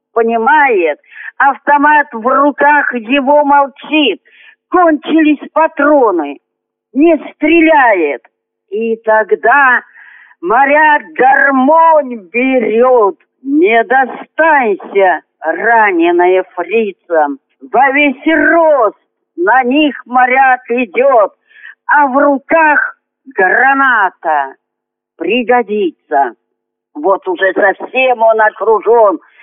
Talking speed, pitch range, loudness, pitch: 75 wpm, 230-310 Hz, -10 LUFS, 275 Hz